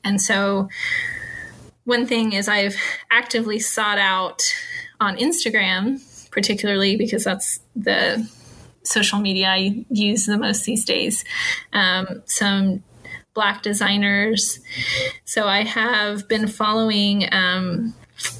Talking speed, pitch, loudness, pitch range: 110 wpm, 215 Hz, -19 LUFS, 200-230 Hz